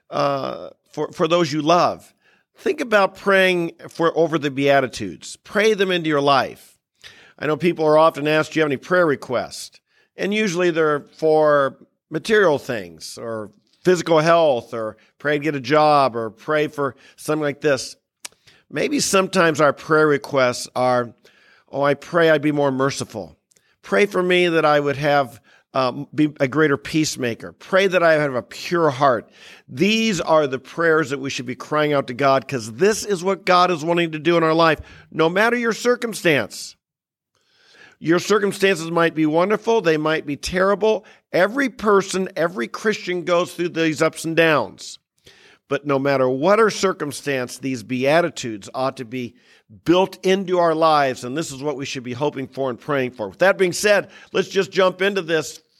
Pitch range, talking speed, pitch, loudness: 140-180 Hz, 180 wpm, 155 Hz, -19 LUFS